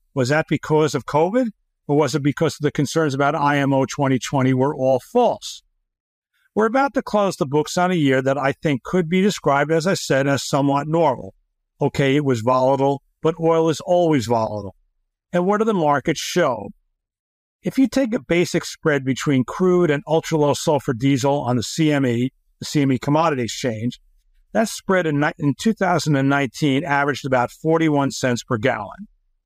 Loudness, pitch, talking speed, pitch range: -20 LUFS, 145 Hz, 175 wpm, 135-170 Hz